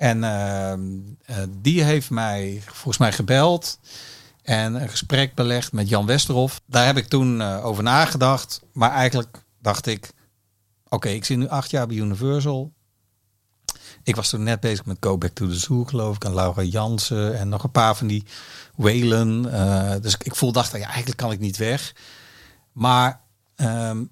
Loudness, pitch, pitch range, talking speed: -22 LUFS, 115 Hz, 105-130 Hz, 180 wpm